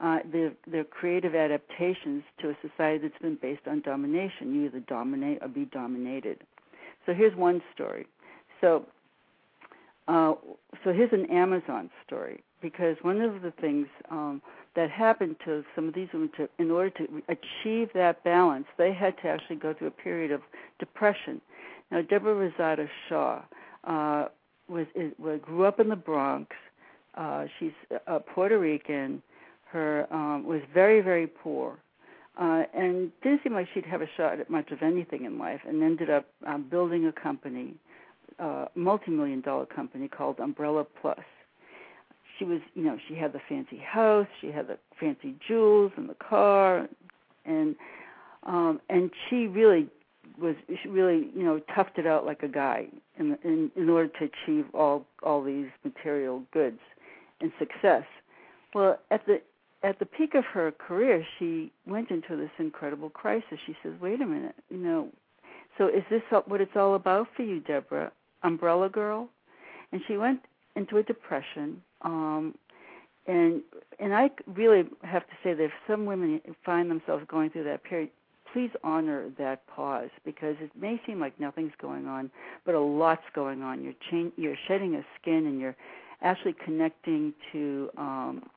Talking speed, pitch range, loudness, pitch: 165 wpm, 155-225 Hz, -29 LUFS, 175 Hz